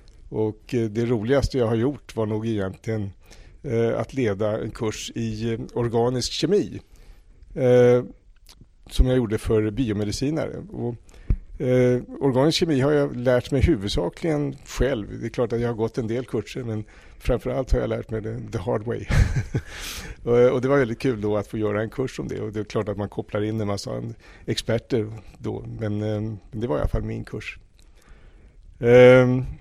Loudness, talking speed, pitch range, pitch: -23 LUFS, 185 wpm, 105-125 Hz, 115 Hz